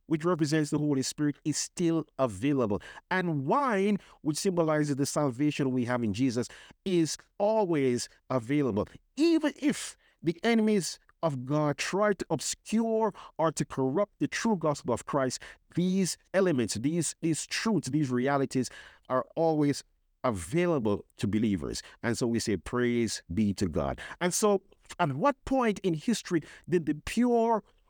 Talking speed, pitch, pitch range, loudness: 145 wpm, 155 Hz, 130-190 Hz, -29 LUFS